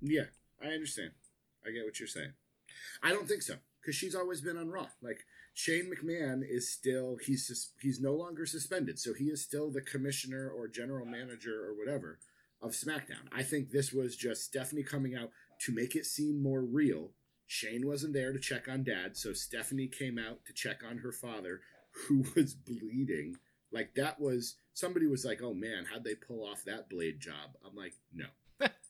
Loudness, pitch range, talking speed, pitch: -37 LUFS, 125-150 Hz, 190 wpm, 135 Hz